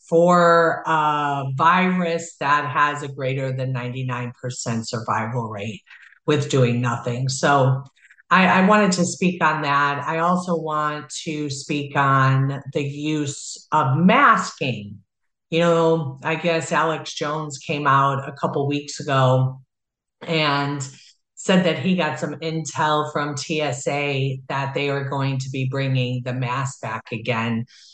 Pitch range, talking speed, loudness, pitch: 130-160 Hz, 135 wpm, -21 LUFS, 145 Hz